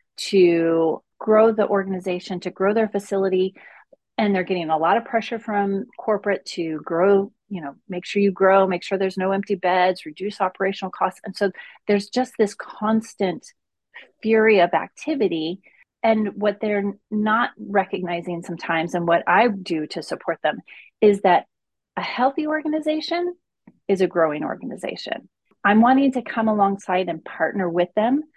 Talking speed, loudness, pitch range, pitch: 155 wpm, -21 LUFS, 180-220 Hz, 195 Hz